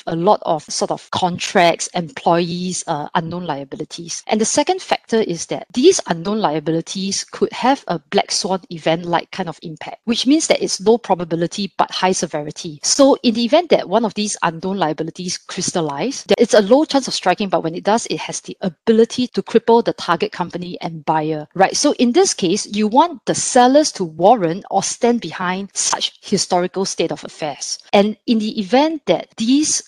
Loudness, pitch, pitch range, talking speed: -17 LUFS, 195 Hz, 170-230 Hz, 190 wpm